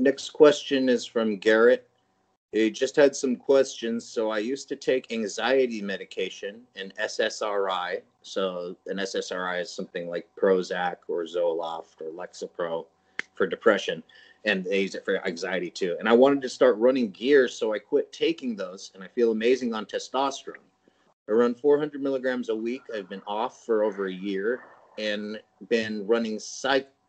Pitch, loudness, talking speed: 135 Hz, -26 LUFS, 165 wpm